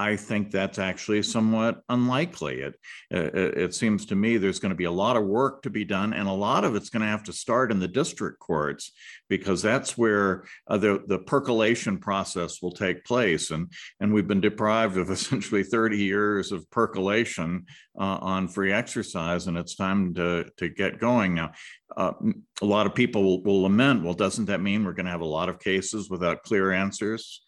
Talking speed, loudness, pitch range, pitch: 205 wpm, -26 LUFS, 95-110 Hz, 100 Hz